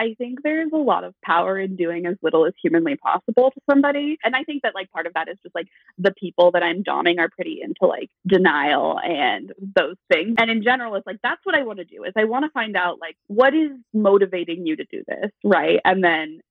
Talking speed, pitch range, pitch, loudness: 250 wpm, 175-265 Hz, 200 Hz, -20 LUFS